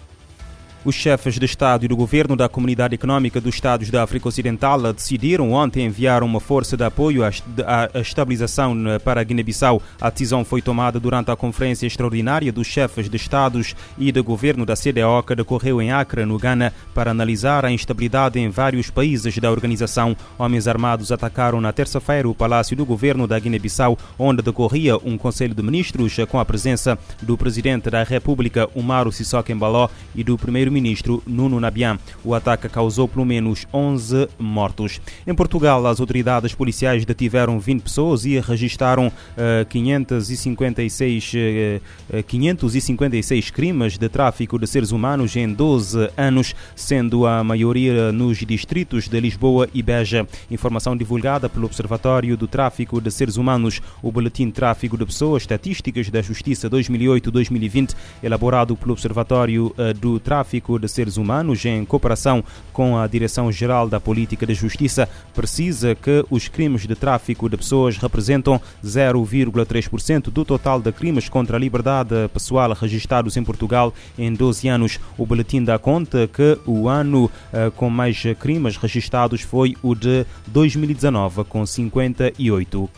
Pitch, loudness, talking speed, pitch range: 120 Hz, -19 LUFS, 150 wpm, 115-130 Hz